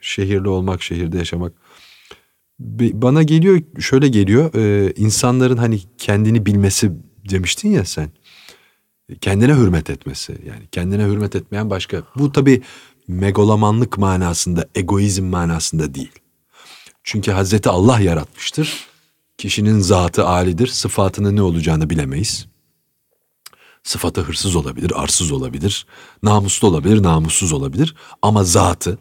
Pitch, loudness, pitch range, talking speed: 100 Hz, -16 LUFS, 90-115 Hz, 110 wpm